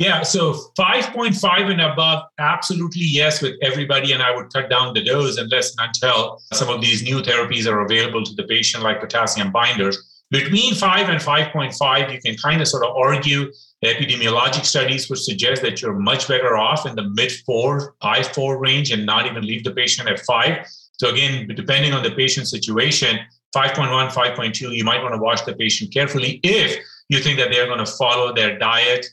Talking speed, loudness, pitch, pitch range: 200 wpm, -18 LUFS, 135 Hz, 120-150 Hz